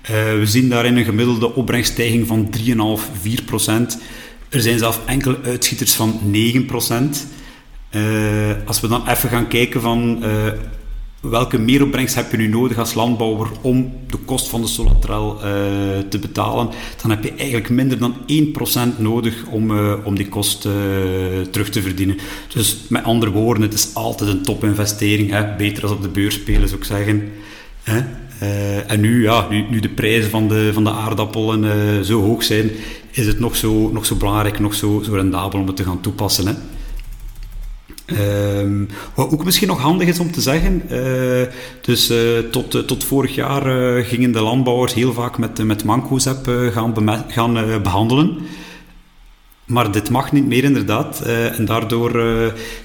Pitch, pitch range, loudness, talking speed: 115 Hz, 105-120 Hz, -17 LUFS, 180 wpm